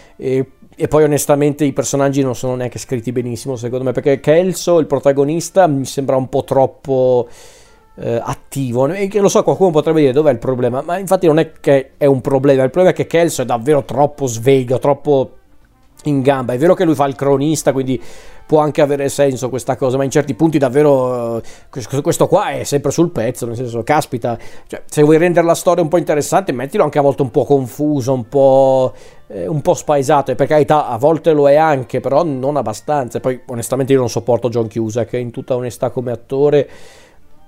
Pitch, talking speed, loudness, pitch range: 140 Hz, 205 wpm, -15 LUFS, 130-150 Hz